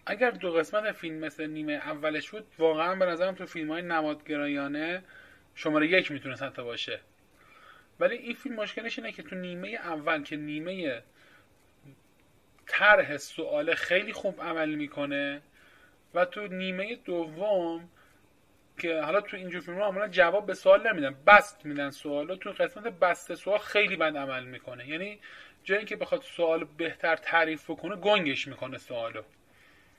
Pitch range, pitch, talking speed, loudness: 150-205 Hz, 170 Hz, 150 wpm, -29 LUFS